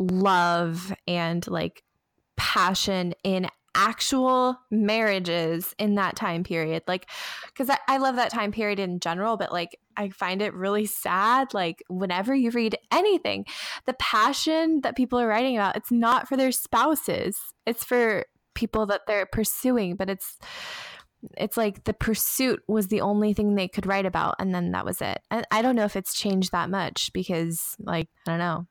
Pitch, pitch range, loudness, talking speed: 205 Hz, 185-235 Hz, -25 LUFS, 175 wpm